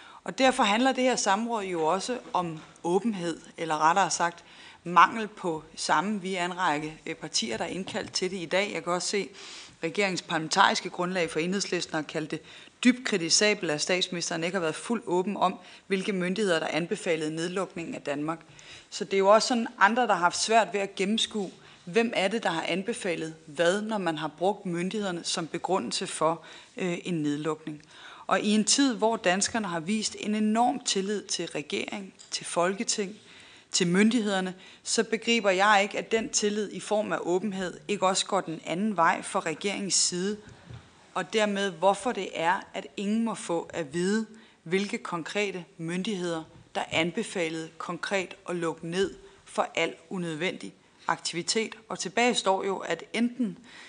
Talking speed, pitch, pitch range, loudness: 175 wpm, 190 Hz, 170-210 Hz, -28 LUFS